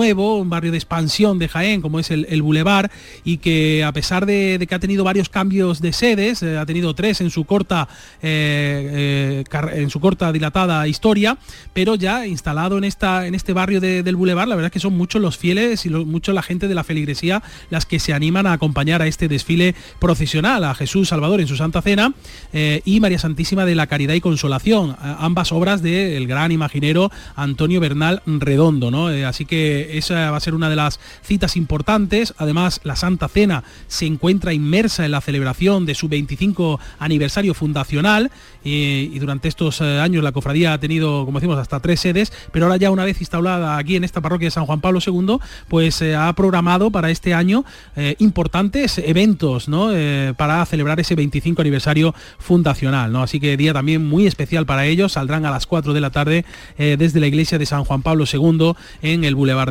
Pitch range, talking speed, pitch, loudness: 150-185 Hz, 205 wpm, 165 Hz, -18 LUFS